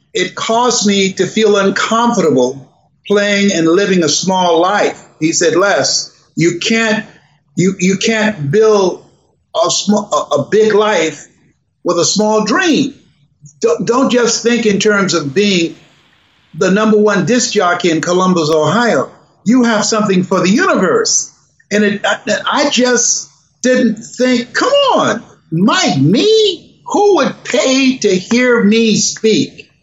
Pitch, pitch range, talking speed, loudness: 205 Hz, 180-235 Hz, 140 wpm, -12 LUFS